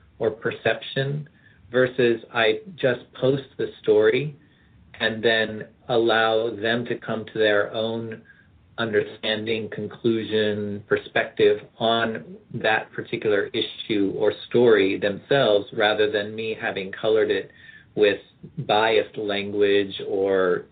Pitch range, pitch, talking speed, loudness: 105-130 Hz, 115 Hz, 105 wpm, -23 LUFS